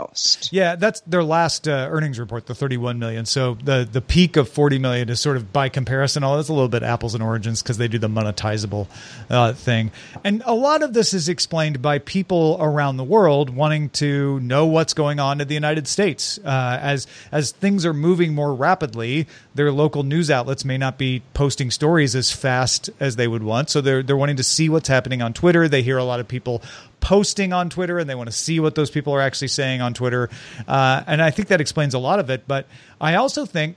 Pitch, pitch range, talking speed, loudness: 140 Hz, 125-160 Hz, 225 wpm, -20 LUFS